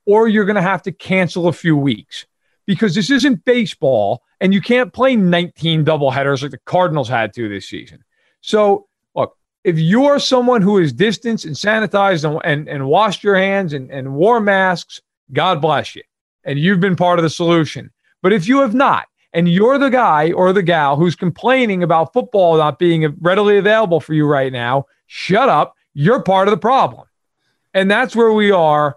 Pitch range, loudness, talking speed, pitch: 155-215 Hz, -15 LUFS, 195 wpm, 185 Hz